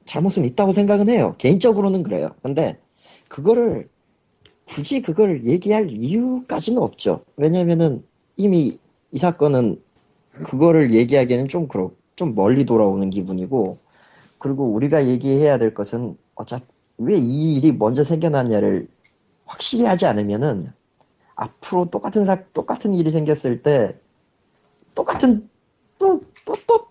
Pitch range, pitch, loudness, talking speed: 125-205 Hz, 160 Hz, -19 LUFS, 285 characters per minute